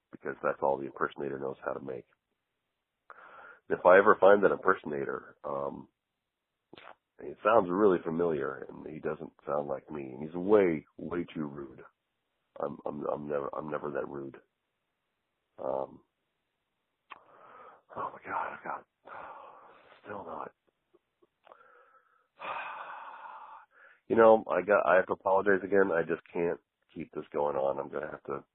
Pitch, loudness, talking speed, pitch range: 75 Hz, -30 LUFS, 145 wpm, 70-95 Hz